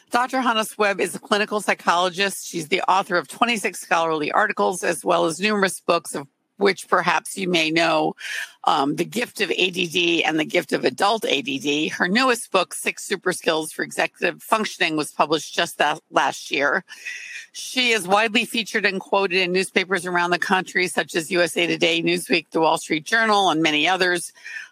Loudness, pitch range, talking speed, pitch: -21 LUFS, 170-210 Hz, 180 wpm, 185 Hz